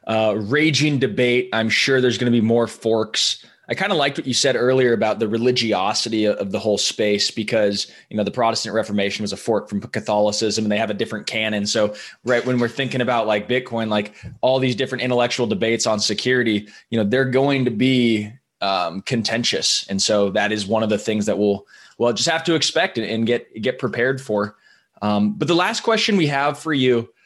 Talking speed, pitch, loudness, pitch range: 210 wpm, 115 Hz, -20 LUFS, 105-125 Hz